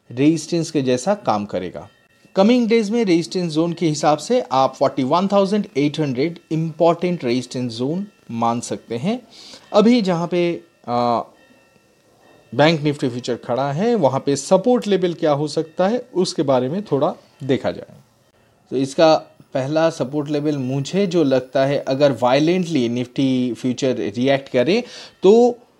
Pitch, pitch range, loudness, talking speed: 155 Hz, 130-185 Hz, -19 LUFS, 140 wpm